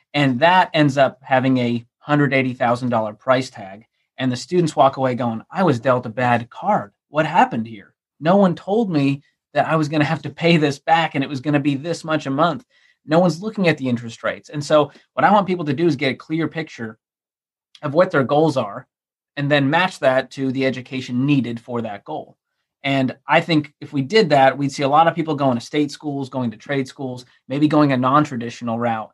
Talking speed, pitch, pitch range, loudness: 230 wpm, 140 Hz, 125-155 Hz, -19 LUFS